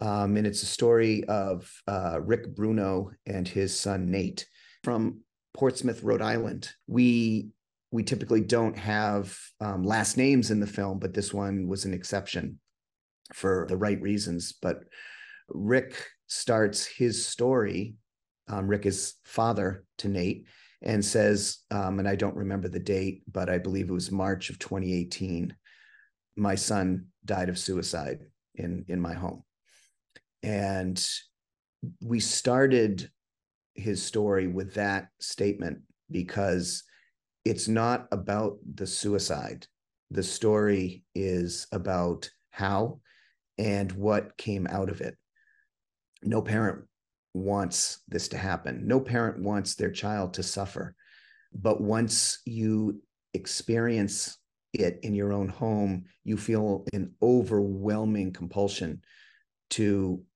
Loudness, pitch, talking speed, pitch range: -29 LUFS, 100 Hz, 125 wpm, 95-110 Hz